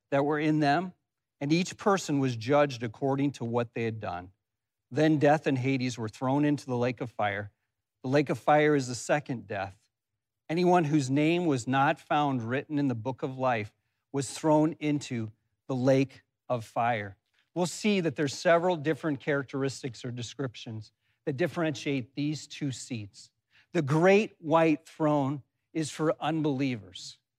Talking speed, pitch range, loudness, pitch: 160 wpm, 120-155 Hz, -29 LUFS, 135 Hz